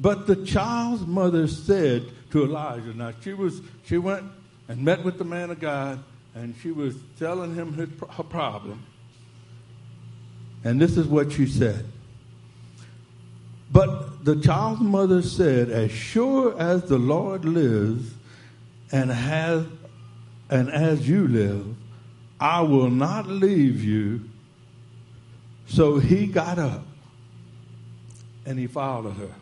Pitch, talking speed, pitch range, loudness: 130 Hz, 130 wpm, 115-165 Hz, -23 LUFS